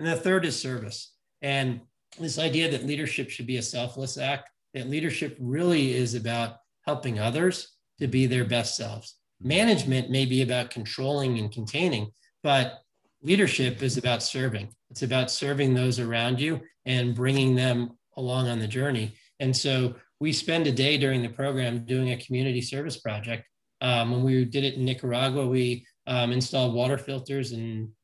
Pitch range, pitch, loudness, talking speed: 120-140 Hz, 130 Hz, -27 LUFS, 170 wpm